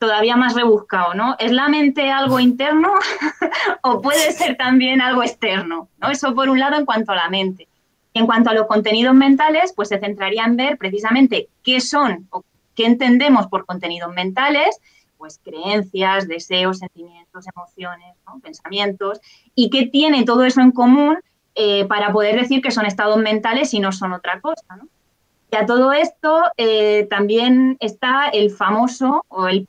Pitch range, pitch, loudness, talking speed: 195-270 Hz, 230 Hz, -16 LUFS, 170 wpm